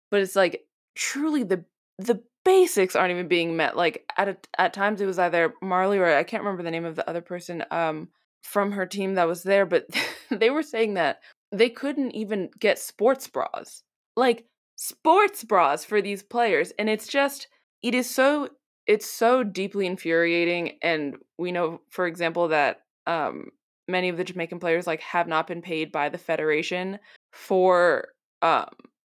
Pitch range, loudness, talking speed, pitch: 170-230 Hz, -24 LUFS, 180 wpm, 190 Hz